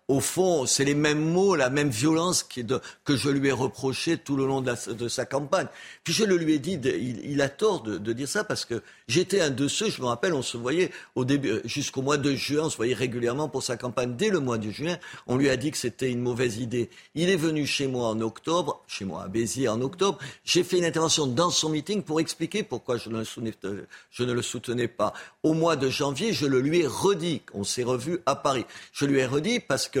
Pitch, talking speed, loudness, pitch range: 140 Hz, 240 wpm, -26 LUFS, 125-165 Hz